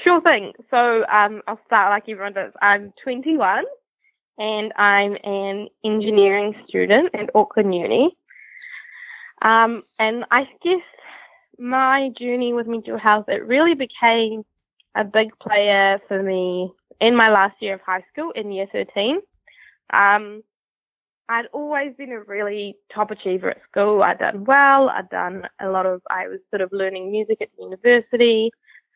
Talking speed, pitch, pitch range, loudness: 150 wpm, 220 Hz, 200-255 Hz, -19 LUFS